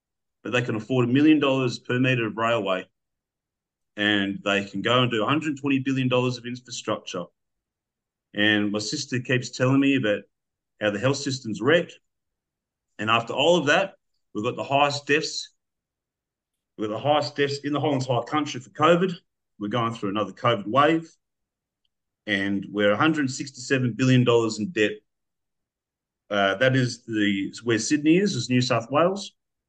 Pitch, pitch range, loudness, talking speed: 125 Hz, 105-140 Hz, -23 LUFS, 160 wpm